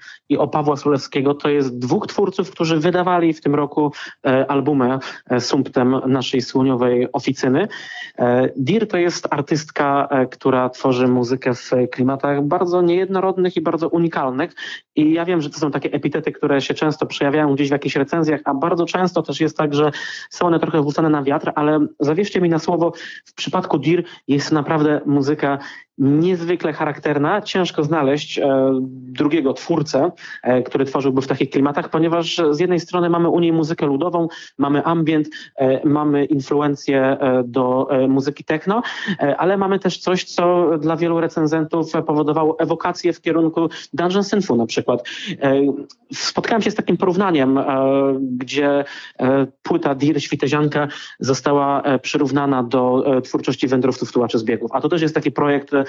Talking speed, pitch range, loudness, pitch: 160 wpm, 135-165 Hz, -18 LUFS, 150 Hz